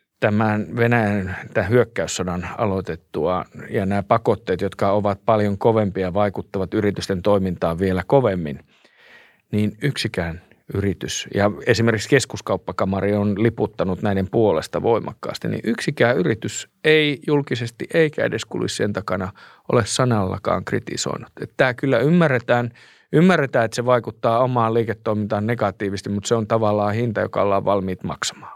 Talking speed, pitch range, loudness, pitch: 130 wpm, 100-120 Hz, -21 LUFS, 105 Hz